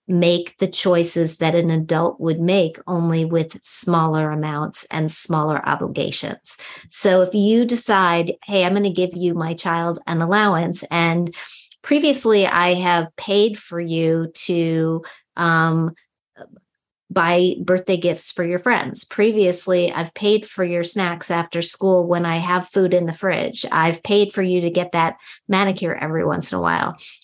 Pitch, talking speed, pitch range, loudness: 175 Hz, 160 wpm, 165-190 Hz, -19 LUFS